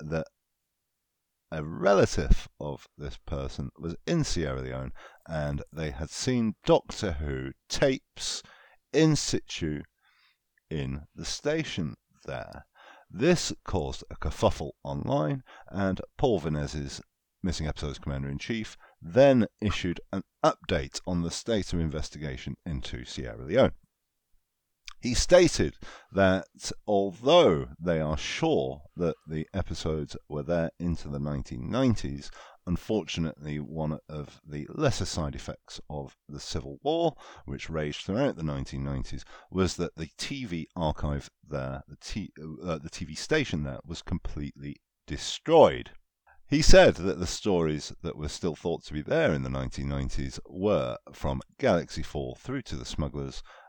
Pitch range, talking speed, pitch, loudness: 70-95 Hz, 130 wpm, 80 Hz, -29 LUFS